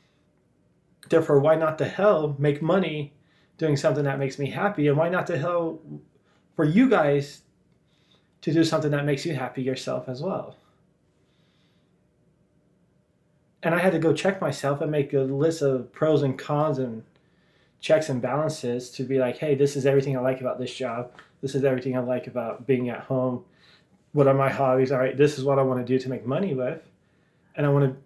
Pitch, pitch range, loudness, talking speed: 140 Hz, 130-160 Hz, -24 LUFS, 195 wpm